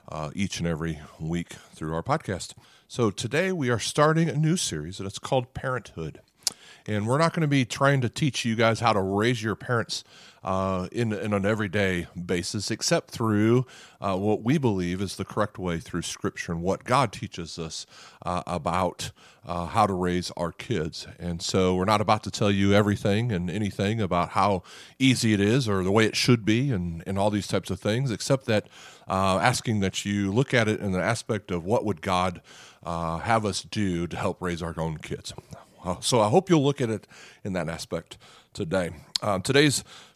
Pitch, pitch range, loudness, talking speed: 105 Hz, 90-120 Hz, -26 LUFS, 205 wpm